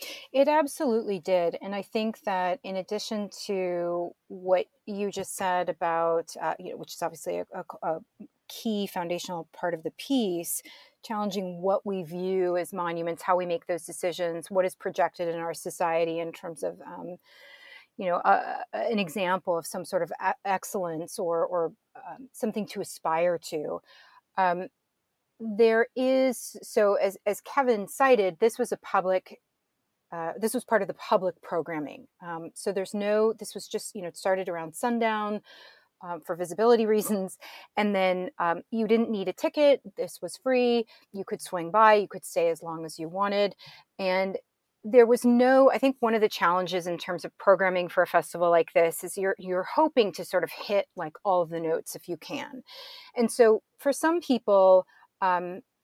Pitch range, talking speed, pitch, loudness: 175-225 Hz, 185 wpm, 195 Hz, -27 LUFS